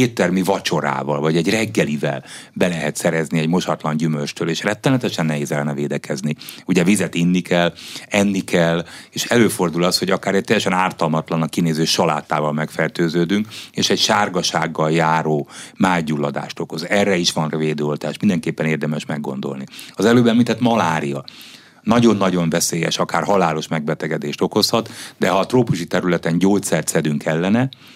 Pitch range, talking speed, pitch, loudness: 80-95 Hz, 140 wpm, 85 Hz, -19 LUFS